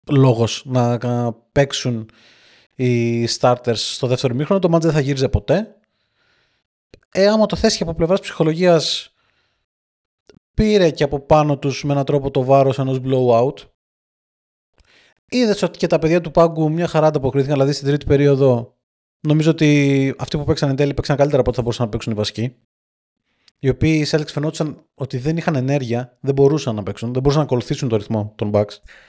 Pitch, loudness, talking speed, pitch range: 140 Hz, -18 LUFS, 180 wpm, 120-155 Hz